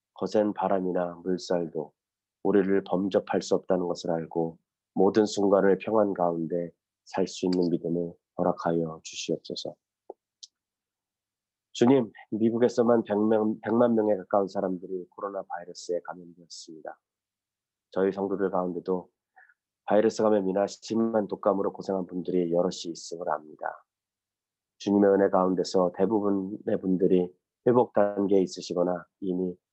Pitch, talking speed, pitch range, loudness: 95 Hz, 295 characters per minute, 90-105 Hz, -27 LUFS